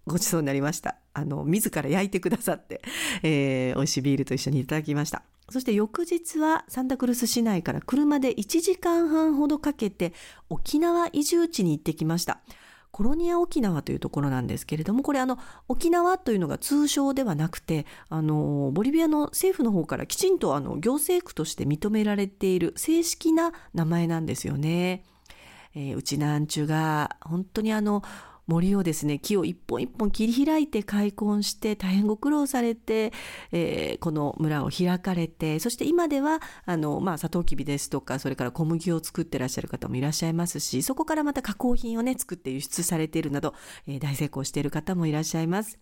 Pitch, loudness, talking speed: 190 Hz, -26 LUFS, 395 characters per minute